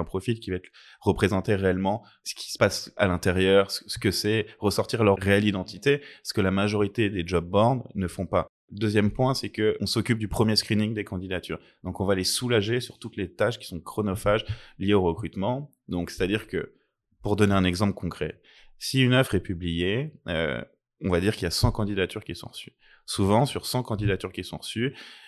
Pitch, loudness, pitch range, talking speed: 100 Hz, -26 LUFS, 95-110 Hz, 215 wpm